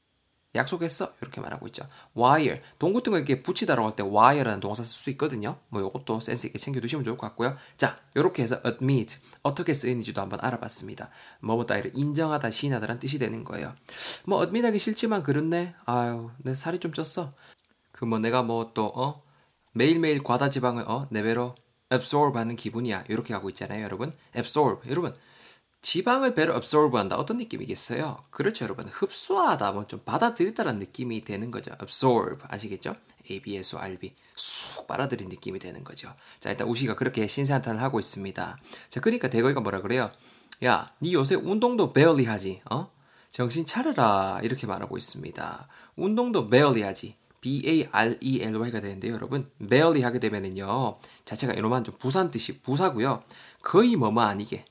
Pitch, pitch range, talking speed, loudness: 125 Hz, 110-150 Hz, 410 characters per minute, -27 LUFS